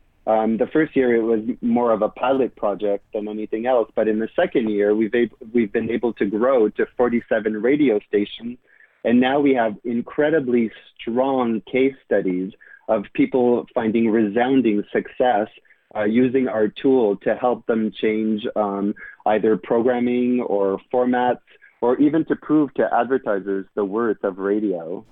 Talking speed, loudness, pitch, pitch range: 160 wpm, -21 LUFS, 115 Hz, 105-125 Hz